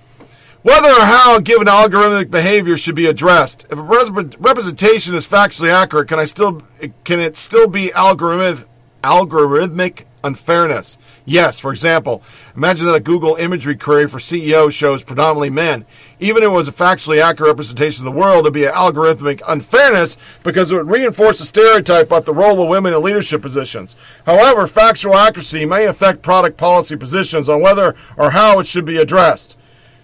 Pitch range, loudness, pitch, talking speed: 145-190 Hz, -12 LUFS, 165 Hz, 175 wpm